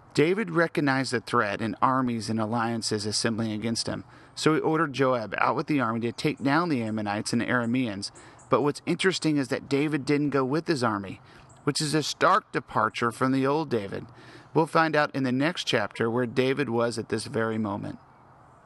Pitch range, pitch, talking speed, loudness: 115-145 Hz, 130 Hz, 195 wpm, -26 LUFS